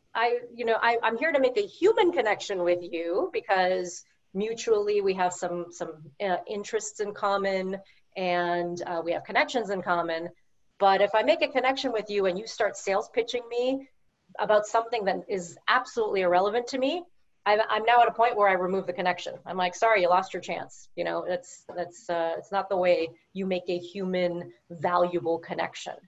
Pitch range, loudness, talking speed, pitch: 180-230 Hz, -27 LUFS, 195 wpm, 195 Hz